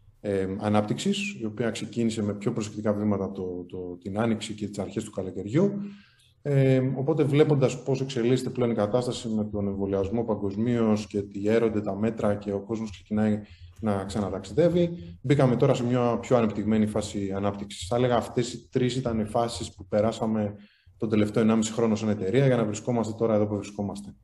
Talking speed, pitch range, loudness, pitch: 180 wpm, 100-120 Hz, -27 LUFS, 110 Hz